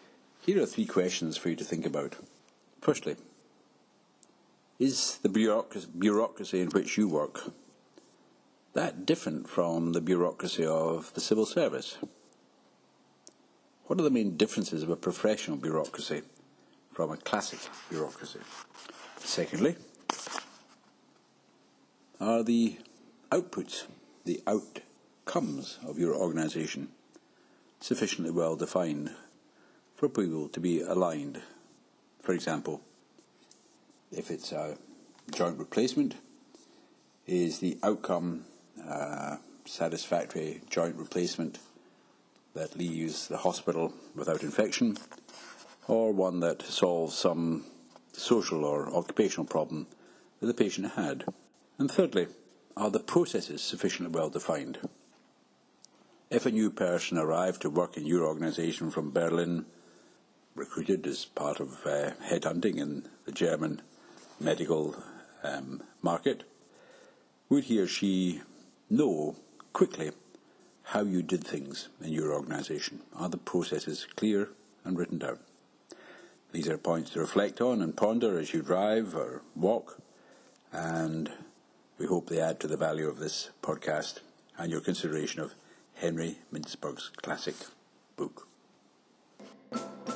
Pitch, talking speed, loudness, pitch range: 85 Hz, 115 wpm, -32 LUFS, 80-105 Hz